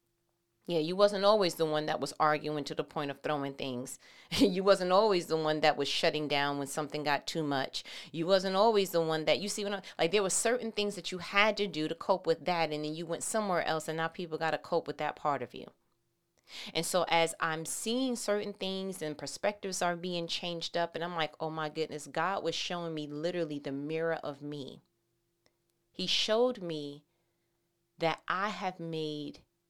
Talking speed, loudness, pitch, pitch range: 210 wpm, -32 LUFS, 165 Hz, 150-190 Hz